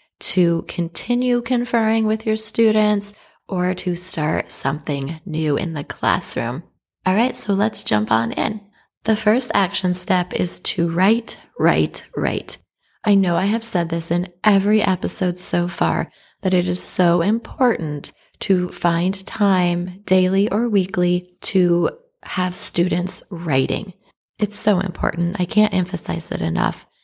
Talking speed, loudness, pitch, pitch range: 140 wpm, -19 LUFS, 185 Hz, 175-210 Hz